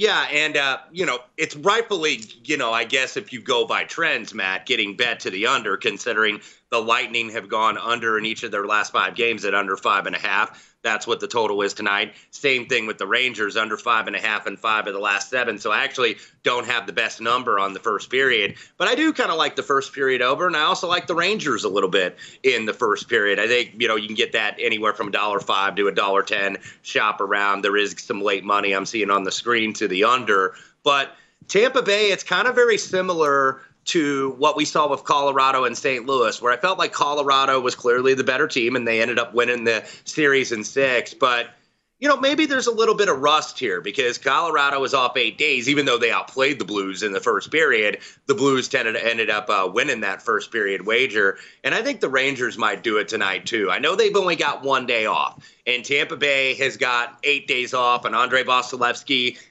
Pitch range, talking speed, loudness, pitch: 115-185 Hz, 235 wpm, -20 LUFS, 135 Hz